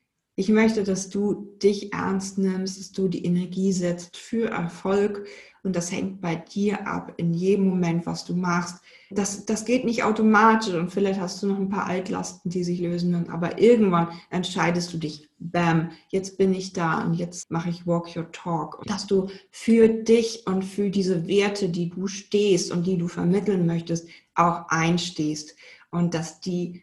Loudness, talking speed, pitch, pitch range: -24 LUFS, 185 wpm, 185 Hz, 170-200 Hz